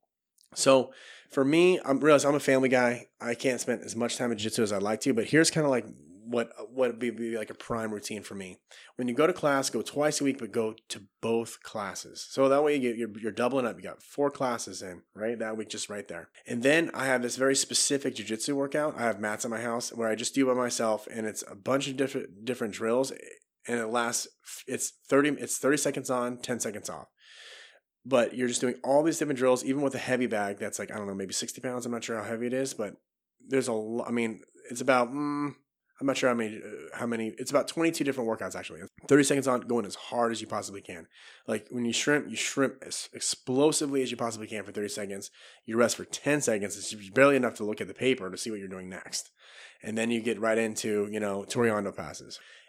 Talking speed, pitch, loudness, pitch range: 245 wpm, 120 Hz, -29 LUFS, 110-135 Hz